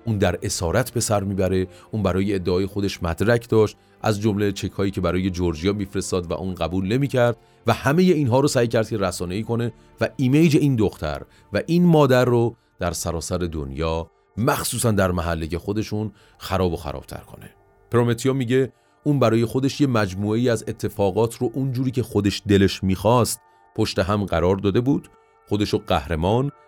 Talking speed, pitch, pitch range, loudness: 175 wpm, 105 Hz, 95-120 Hz, -22 LUFS